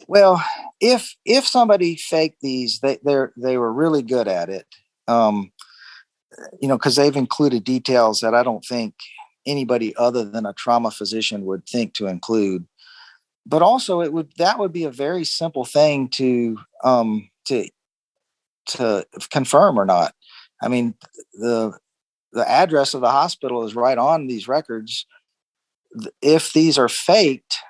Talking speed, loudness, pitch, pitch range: 150 wpm, -19 LUFS, 130 Hz, 115-160 Hz